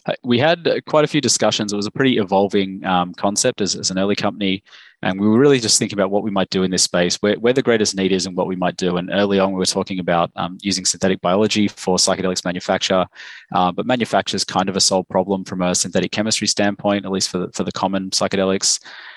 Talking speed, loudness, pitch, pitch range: 245 wpm, -18 LUFS, 95 Hz, 95-105 Hz